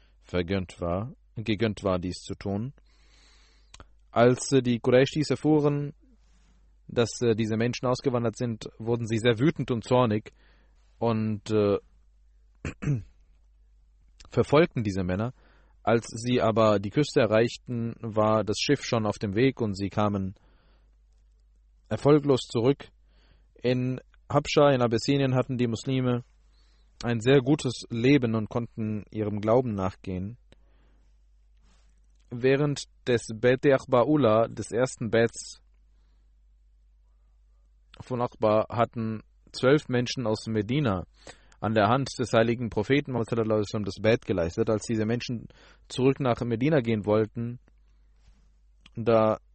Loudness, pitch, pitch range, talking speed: -26 LUFS, 115 Hz, 95-125 Hz, 115 wpm